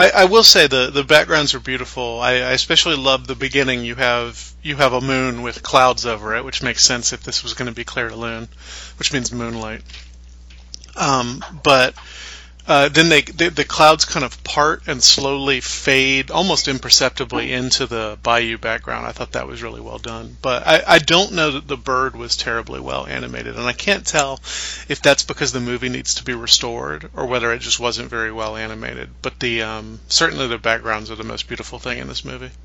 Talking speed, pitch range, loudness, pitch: 210 wpm, 110-140 Hz, -16 LUFS, 125 Hz